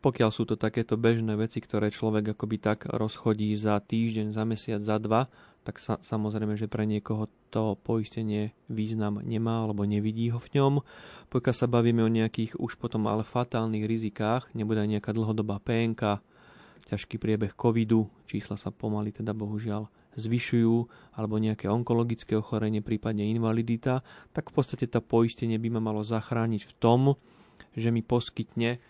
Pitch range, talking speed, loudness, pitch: 105-115 Hz, 160 wpm, -29 LUFS, 110 Hz